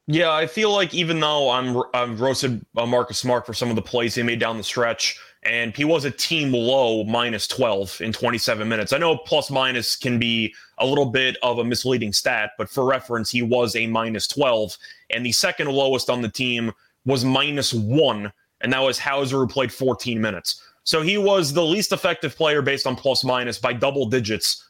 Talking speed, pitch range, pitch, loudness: 205 wpm, 115-140 Hz, 125 Hz, -21 LUFS